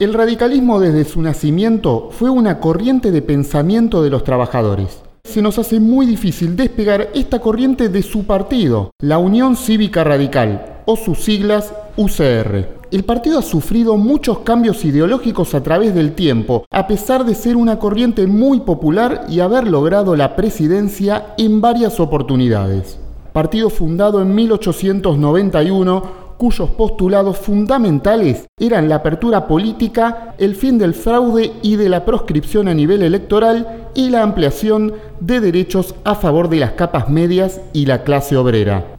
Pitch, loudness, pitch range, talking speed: 195 Hz, -14 LUFS, 155-225 Hz, 150 wpm